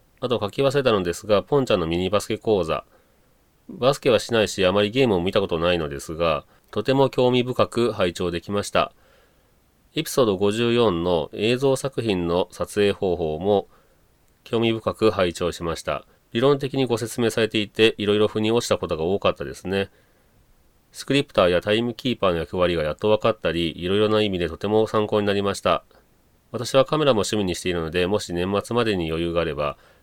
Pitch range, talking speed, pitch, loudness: 90-115 Hz, 385 characters per minute, 105 Hz, -22 LUFS